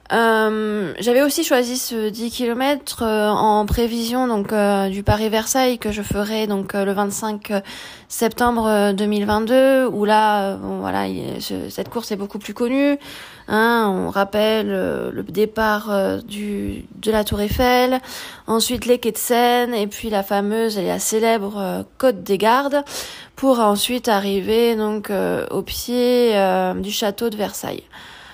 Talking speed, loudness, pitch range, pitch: 160 wpm, -19 LUFS, 205-240 Hz, 215 Hz